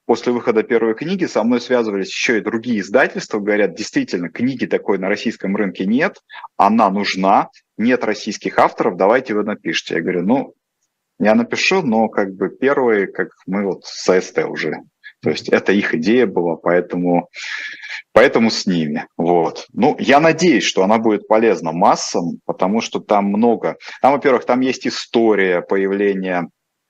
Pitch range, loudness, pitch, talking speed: 100-125 Hz, -17 LUFS, 110 Hz, 160 wpm